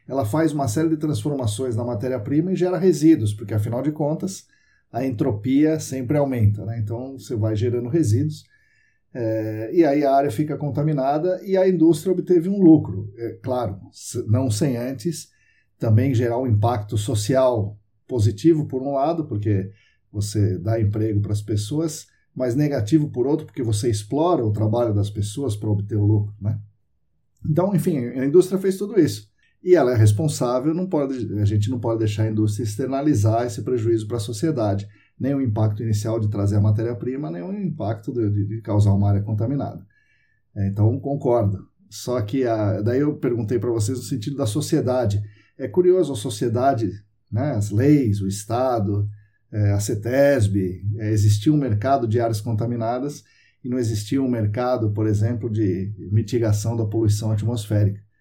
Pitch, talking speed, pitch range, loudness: 120 Hz, 170 wpm, 105-140 Hz, -22 LUFS